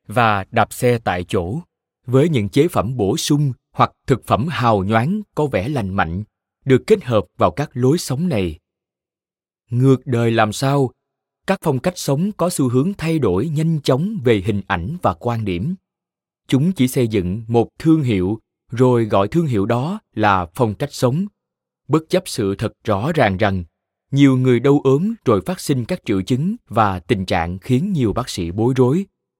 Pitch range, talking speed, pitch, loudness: 105-155 Hz, 185 wpm, 125 Hz, -18 LUFS